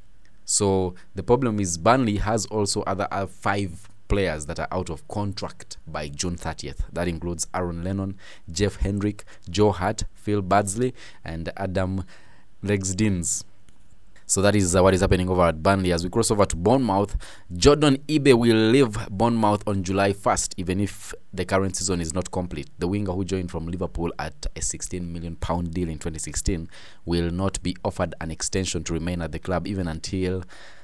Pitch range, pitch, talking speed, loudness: 85-100 Hz, 95 Hz, 175 wpm, -24 LUFS